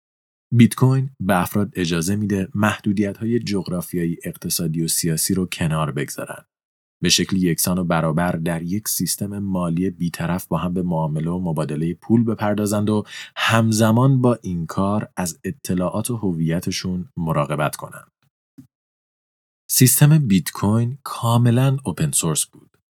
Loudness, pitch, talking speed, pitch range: -20 LUFS, 95 Hz, 135 wpm, 85-110 Hz